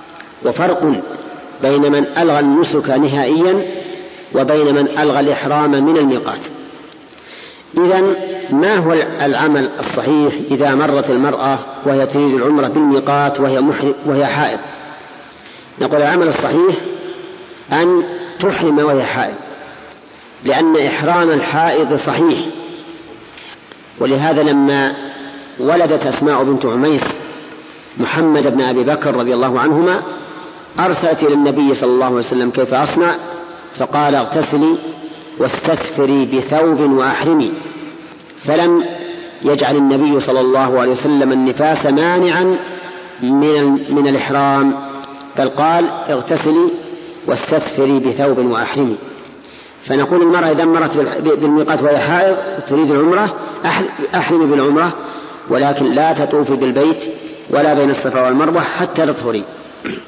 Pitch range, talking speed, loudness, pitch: 140-165 Hz, 105 wpm, -14 LUFS, 145 Hz